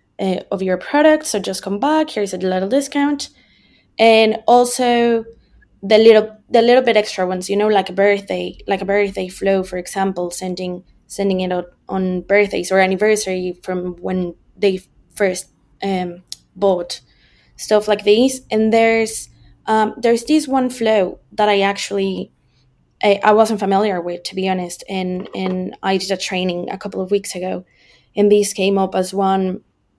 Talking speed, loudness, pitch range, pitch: 170 wpm, -17 LUFS, 185-215 Hz, 195 Hz